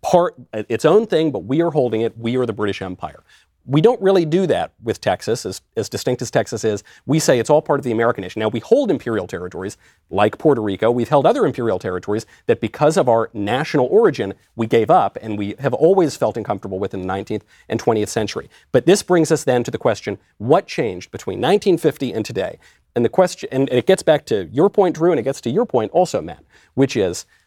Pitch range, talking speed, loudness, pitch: 110-155 Hz, 230 wpm, -18 LUFS, 125 Hz